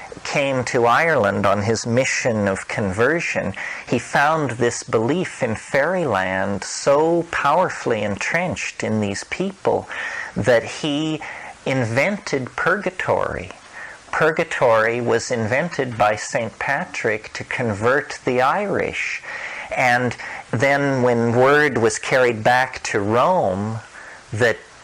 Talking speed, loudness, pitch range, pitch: 105 wpm, -20 LUFS, 110-140 Hz, 125 Hz